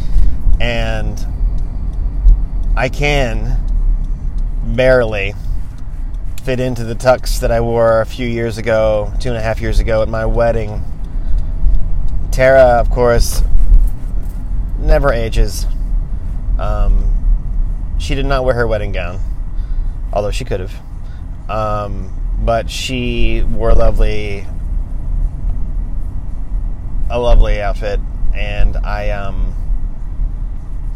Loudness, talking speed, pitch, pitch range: -18 LUFS, 105 wpm, 100 Hz, 85-115 Hz